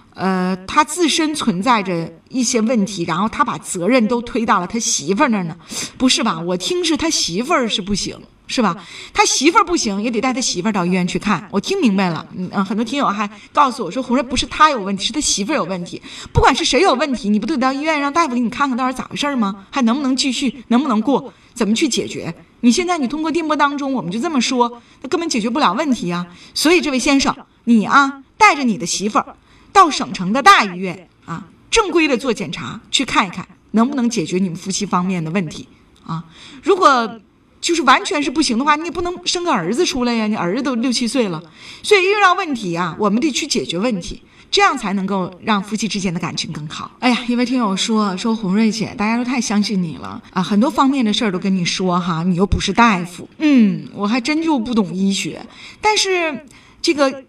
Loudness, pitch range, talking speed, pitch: -17 LUFS, 195-285 Hz, 335 characters per minute, 235 Hz